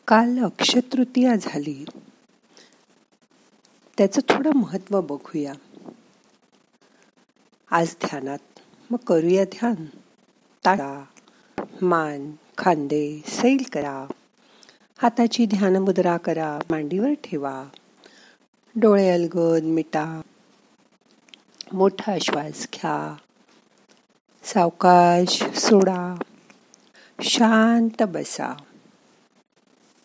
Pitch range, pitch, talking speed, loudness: 160-235 Hz, 195 Hz, 70 wpm, -22 LUFS